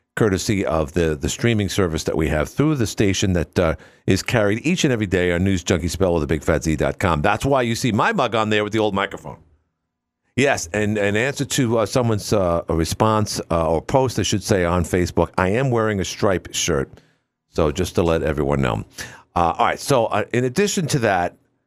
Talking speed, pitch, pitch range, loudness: 215 wpm, 100 Hz, 85-115 Hz, -20 LUFS